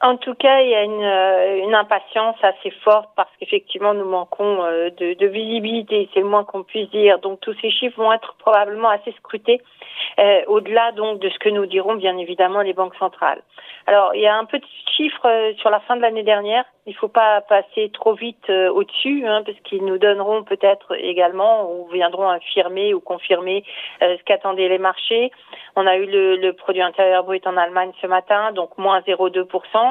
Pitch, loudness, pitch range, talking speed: 205 Hz, -18 LUFS, 190-220 Hz, 205 wpm